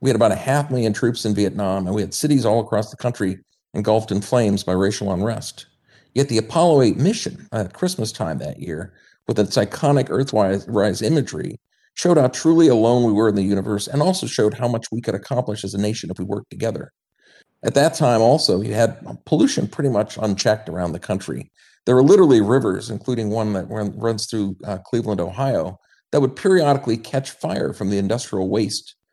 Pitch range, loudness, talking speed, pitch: 100-125 Hz, -20 LUFS, 195 wpm, 110 Hz